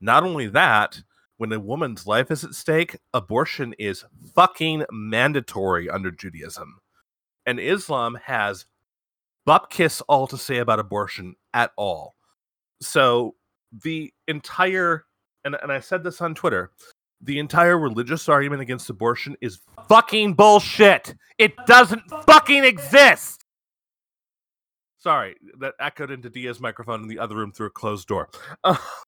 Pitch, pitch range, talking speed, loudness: 140 Hz, 110-170 Hz, 135 wpm, -19 LUFS